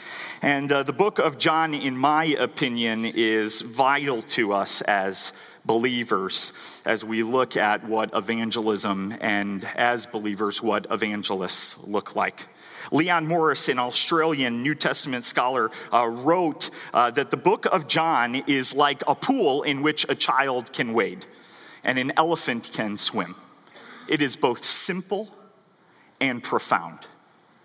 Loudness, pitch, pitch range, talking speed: -23 LUFS, 130 Hz, 115-155 Hz, 140 wpm